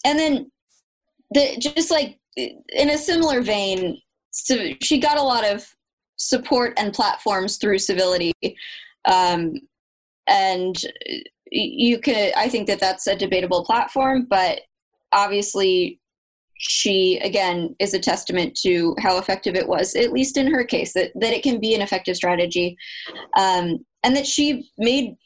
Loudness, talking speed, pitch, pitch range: -20 LUFS, 145 wpm, 240 Hz, 190-285 Hz